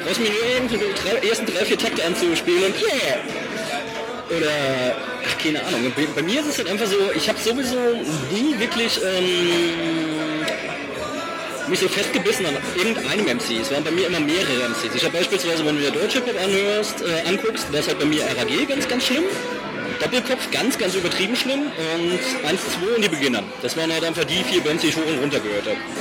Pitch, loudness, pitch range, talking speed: 205 Hz, -21 LUFS, 165-255 Hz, 200 wpm